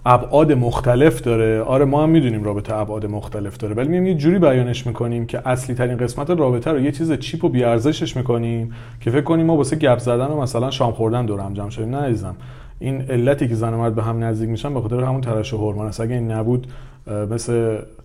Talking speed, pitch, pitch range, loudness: 215 wpm, 120 Hz, 115-140 Hz, -19 LUFS